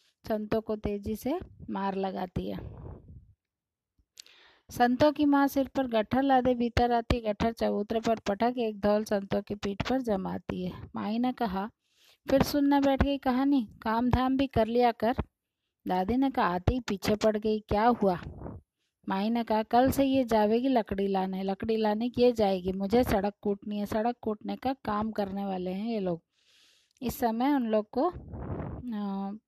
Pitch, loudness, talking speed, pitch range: 220 Hz, -29 LUFS, 165 wpm, 205-250 Hz